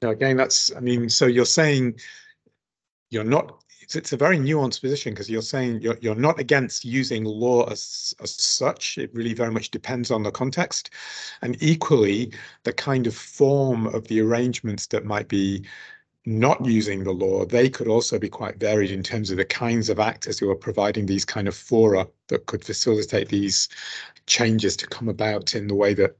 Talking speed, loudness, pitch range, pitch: 190 wpm, -22 LUFS, 110-135 Hz, 115 Hz